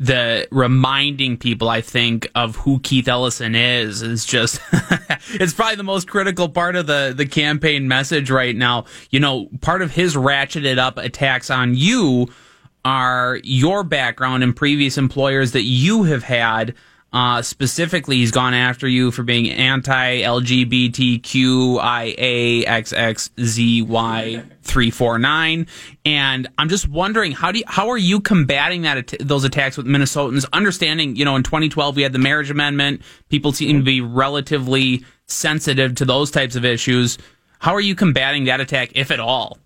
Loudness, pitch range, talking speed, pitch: -17 LUFS, 125-150 Hz, 155 wpm, 135 Hz